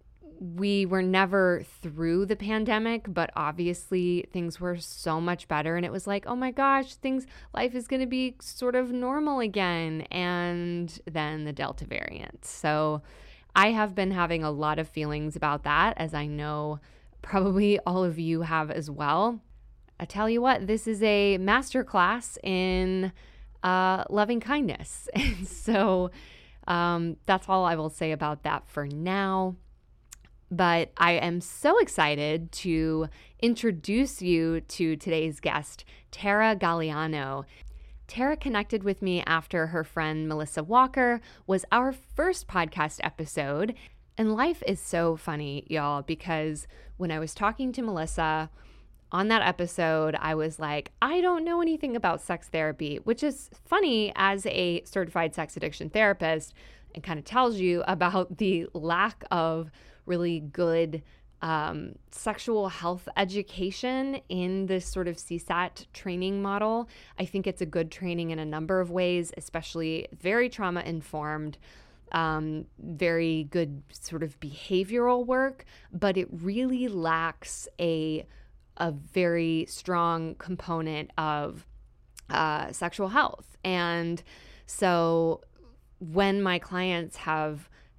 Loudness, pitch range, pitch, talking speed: -28 LUFS, 160-200 Hz, 175 Hz, 140 wpm